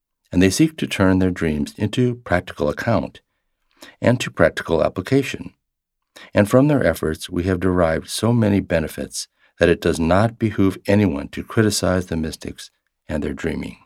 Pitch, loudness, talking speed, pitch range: 95 Hz, -20 LUFS, 160 wpm, 85-110 Hz